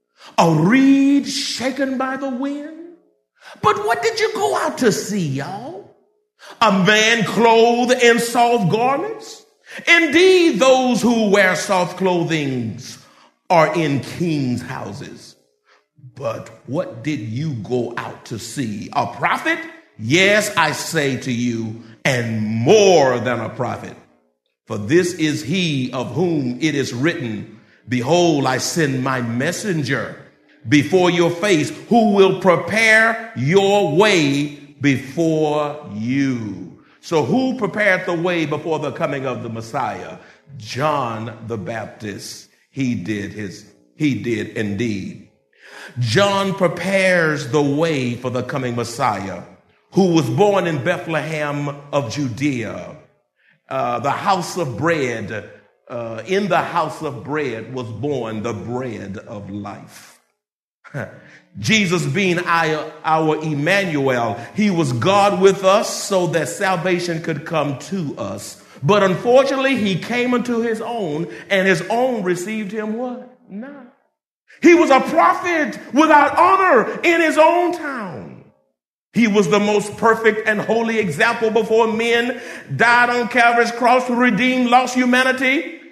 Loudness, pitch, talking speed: -17 LUFS, 175 Hz, 130 wpm